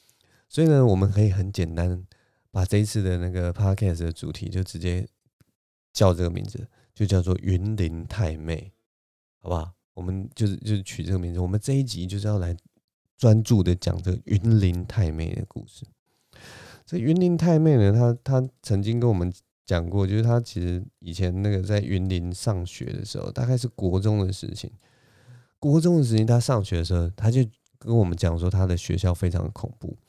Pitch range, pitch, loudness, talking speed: 90-115 Hz, 100 Hz, -24 LUFS, 290 characters per minute